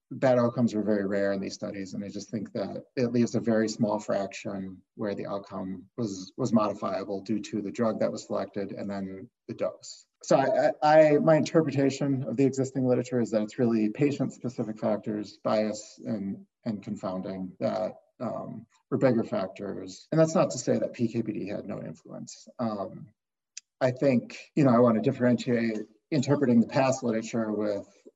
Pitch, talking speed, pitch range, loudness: 115 Hz, 180 wpm, 100-130 Hz, -28 LUFS